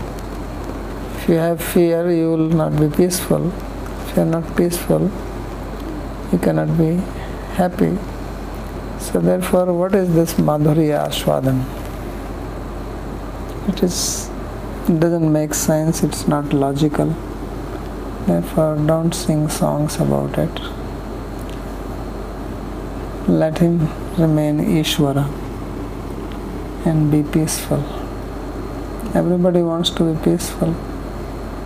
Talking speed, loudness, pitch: 95 wpm, -20 LUFS, 155 Hz